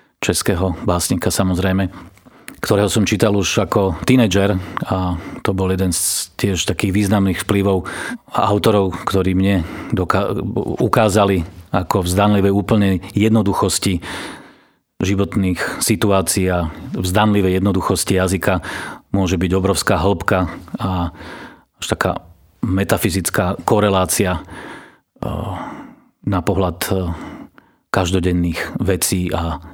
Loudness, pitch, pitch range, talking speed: -18 LUFS, 95 Hz, 90-100 Hz, 95 wpm